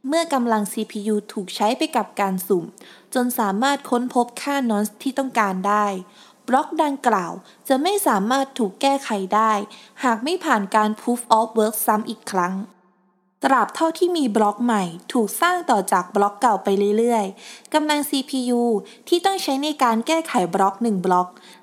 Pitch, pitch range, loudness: 225 Hz, 205-270 Hz, -21 LUFS